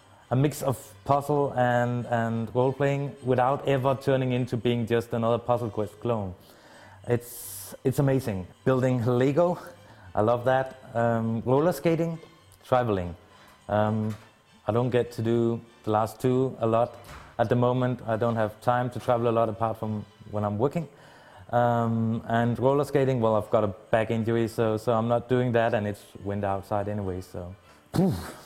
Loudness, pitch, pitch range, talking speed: -26 LUFS, 115 Hz, 110-125 Hz, 170 wpm